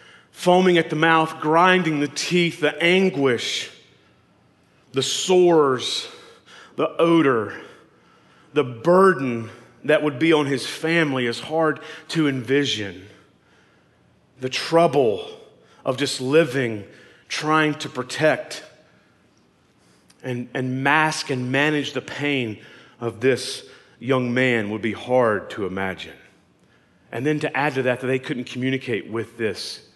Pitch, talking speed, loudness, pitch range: 145 Hz, 120 wpm, -21 LUFS, 125-160 Hz